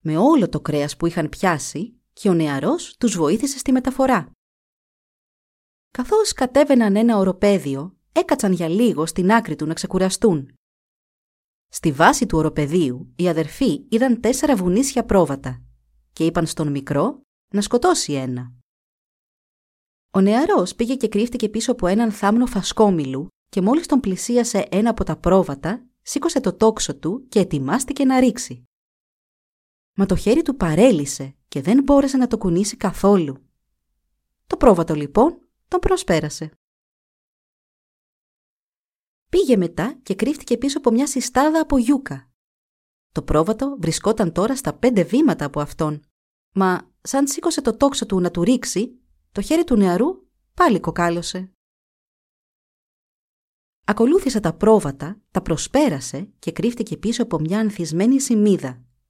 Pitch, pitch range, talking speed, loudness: 200 Hz, 160-250 Hz, 135 wpm, -19 LUFS